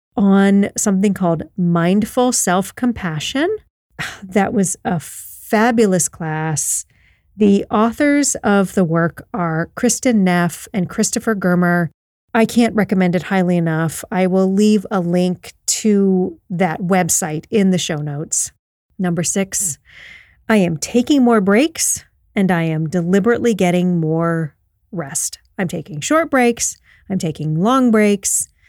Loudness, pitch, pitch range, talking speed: -17 LUFS, 190 Hz, 170-220 Hz, 130 wpm